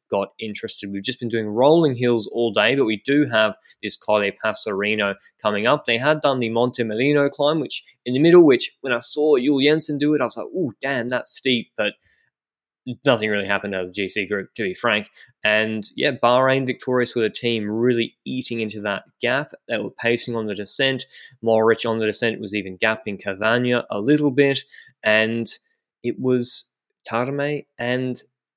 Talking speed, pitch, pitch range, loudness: 190 wpm, 120 Hz, 110-135 Hz, -21 LUFS